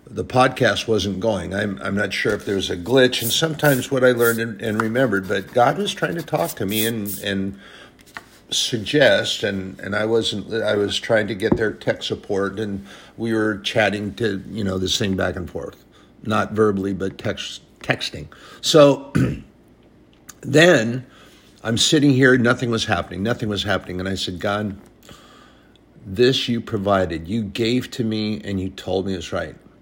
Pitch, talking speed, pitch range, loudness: 110 Hz, 180 wpm, 95-120 Hz, -20 LUFS